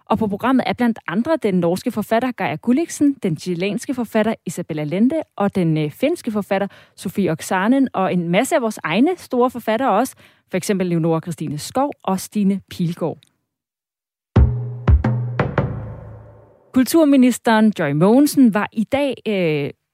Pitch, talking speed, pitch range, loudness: 205 Hz, 140 wpm, 170-245 Hz, -19 LUFS